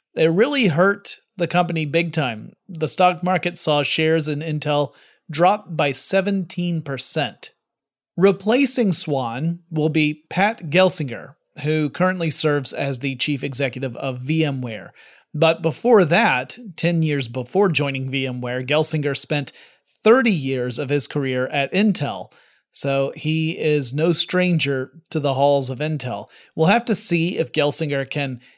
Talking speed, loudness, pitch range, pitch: 140 wpm, -20 LUFS, 140-175 Hz, 155 Hz